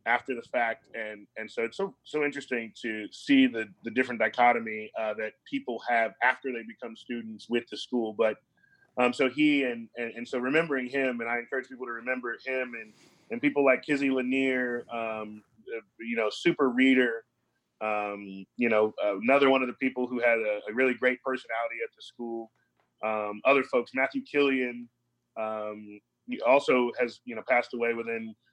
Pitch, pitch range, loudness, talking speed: 120 Hz, 115-130 Hz, -28 LUFS, 185 wpm